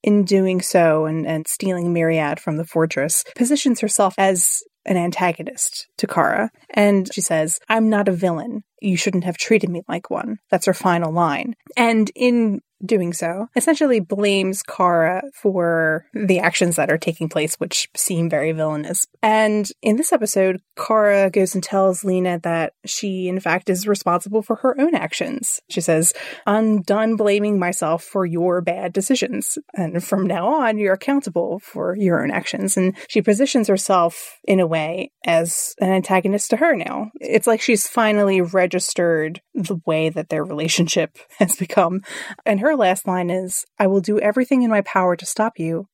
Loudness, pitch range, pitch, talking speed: -19 LUFS, 170-215 Hz, 190 Hz, 175 wpm